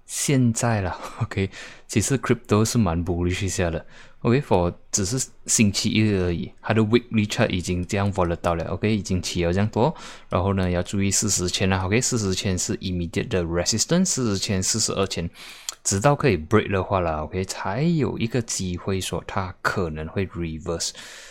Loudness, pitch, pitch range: -23 LUFS, 100 Hz, 90-110 Hz